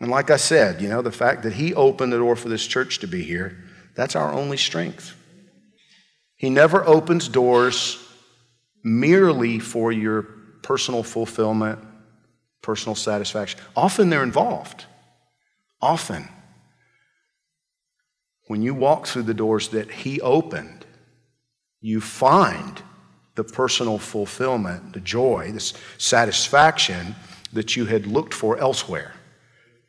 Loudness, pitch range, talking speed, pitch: -21 LUFS, 110-155 Hz, 125 wpm, 125 Hz